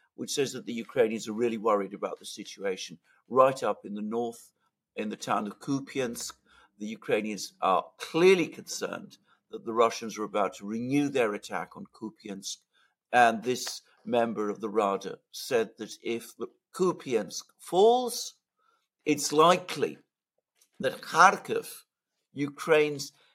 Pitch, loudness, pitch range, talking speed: 120 Hz, -28 LUFS, 110-150 Hz, 135 wpm